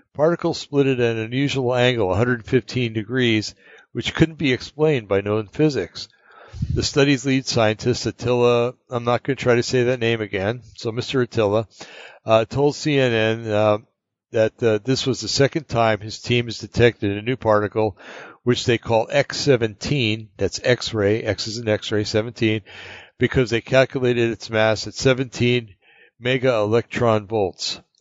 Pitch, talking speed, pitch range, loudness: 120 Hz, 155 wpm, 110-130 Hz, -21 LUFS